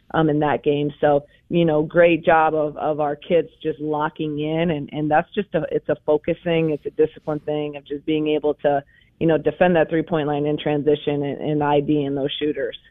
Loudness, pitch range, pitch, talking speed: -21 LUFS, 145-160 Hz, 150 Hz, 225 wpm